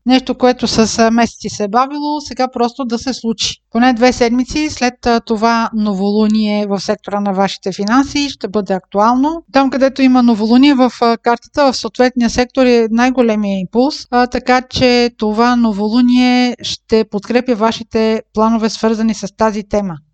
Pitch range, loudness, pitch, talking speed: 215-250 Hz, -14 LUFS, 235 Hz, 150 wpm